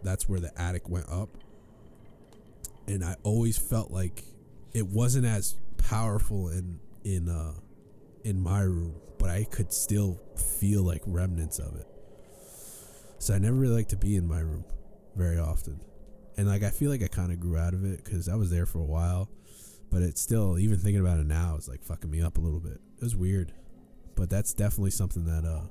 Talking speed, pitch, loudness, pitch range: 200 wpm, 95 Hz, -30 LUFS, 85-105 Hz